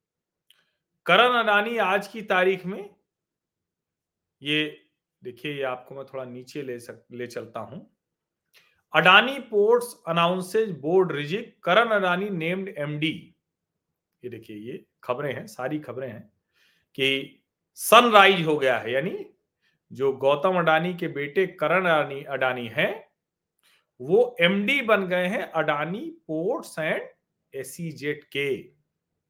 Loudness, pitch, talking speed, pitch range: -23 LUFS, 165 Hz, 120 wpm, 140-200 Hz